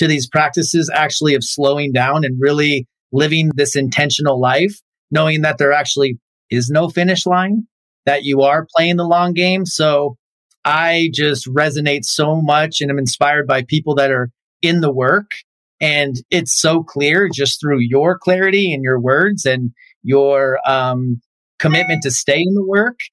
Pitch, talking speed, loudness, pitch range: 145 Hz, 165 wpm, -15 LUFS, 135-165 Hz